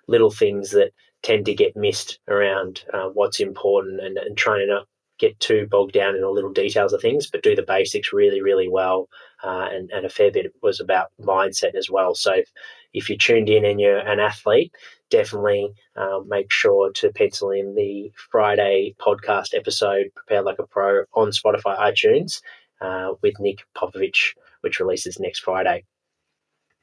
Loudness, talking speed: -20 LUFS, 180 wpm